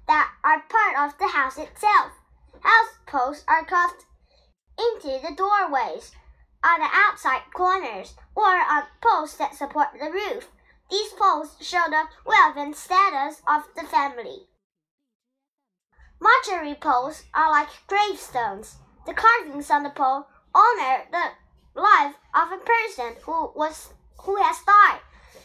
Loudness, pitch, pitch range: -21 LUFS, 325 Hz, 290-405 Hz